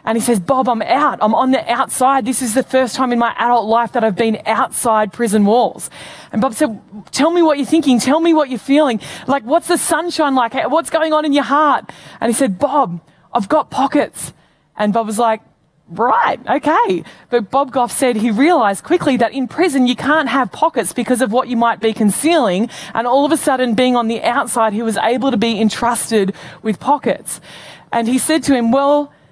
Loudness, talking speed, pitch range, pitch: -15 LUFS, 215 wpm, 230-285 Hz, 250 Hz